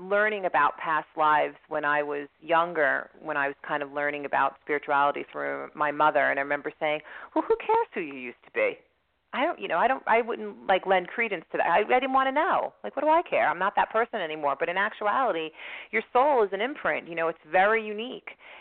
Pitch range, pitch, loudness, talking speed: 145-225 Hz, 170 Hz, -26 LUFS, 235 wpm